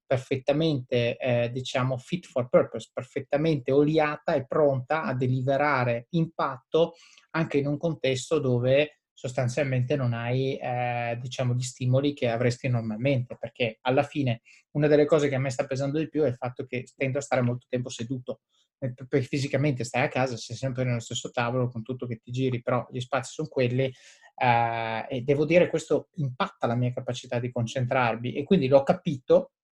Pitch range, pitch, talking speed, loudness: 125-145 Hz, 130 Hz, 175 wpm, -27 LUFS